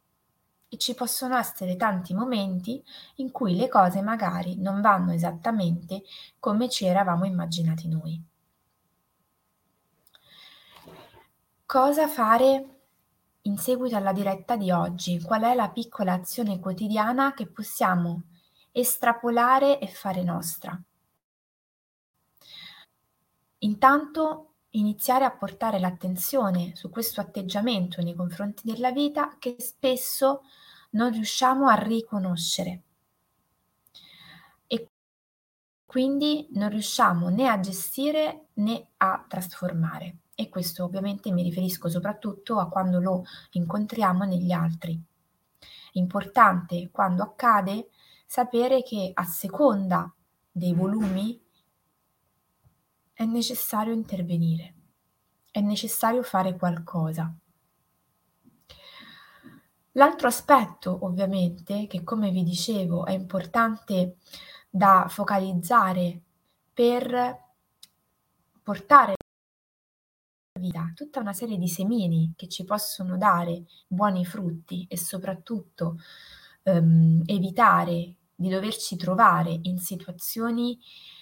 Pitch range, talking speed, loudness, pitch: 180-235 Hz, 95 wpm, -25 LUFS, 195 Hz